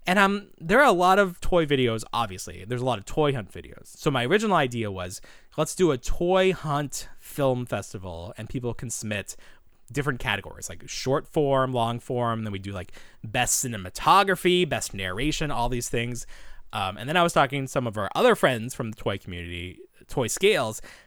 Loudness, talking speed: -25 LUFS, 195 wpm